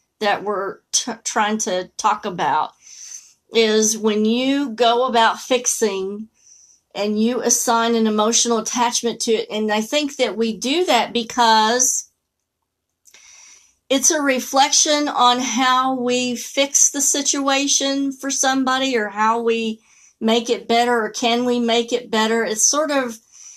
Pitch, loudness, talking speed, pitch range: 235 Hz, -18 LUFS, 140 wpm, 220-260 Hz